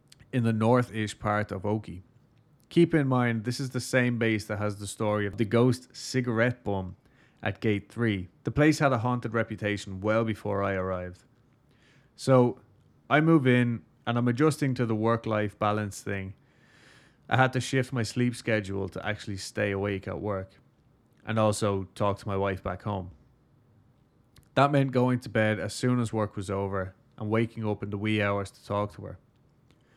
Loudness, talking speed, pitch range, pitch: -28 LUFS, 185 wpm, 105-125 Hz, 115 Hz